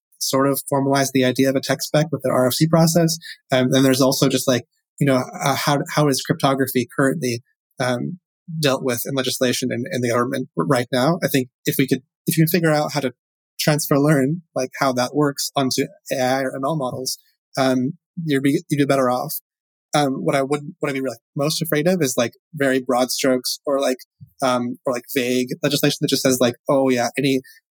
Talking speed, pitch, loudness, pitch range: 215 wpm, 135 Hz, -20 LUFS, 130-150 Hz